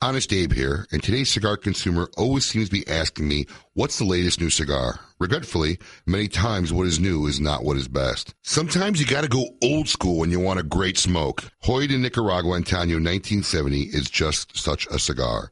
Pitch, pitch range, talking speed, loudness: 90 Hz, 75-110 Hz, 200 wpm, -23 LUFS